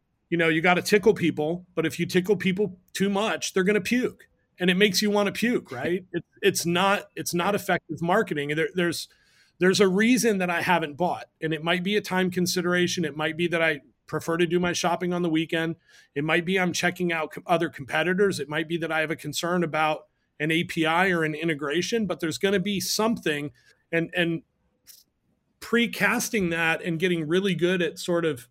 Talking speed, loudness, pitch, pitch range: 210 wpm, -25 LUFS, 175 Hz, 160-190 Hz